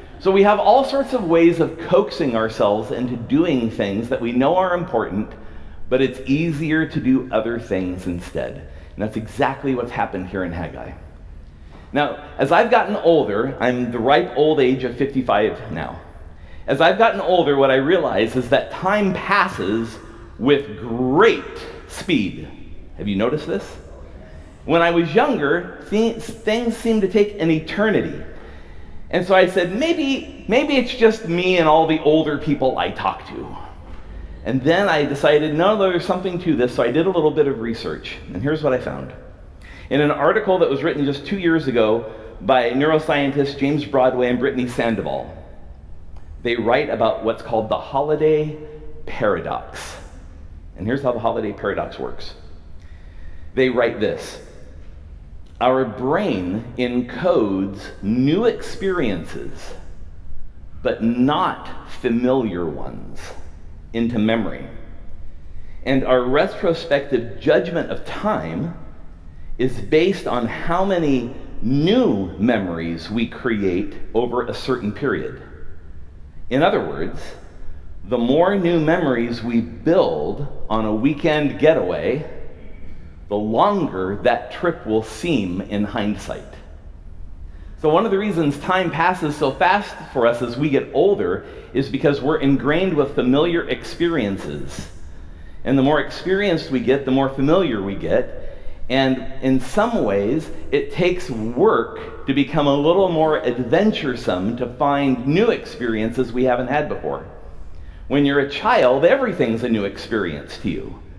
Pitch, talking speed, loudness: 125 Hz, 140 wpm, -19 LUFS